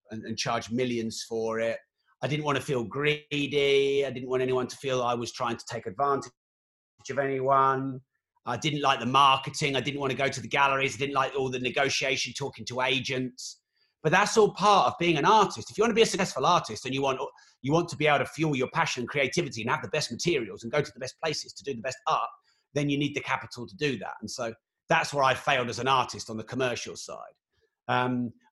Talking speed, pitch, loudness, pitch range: 240 wpm, 135 Hz, -27 LUFS, 125-145 Hz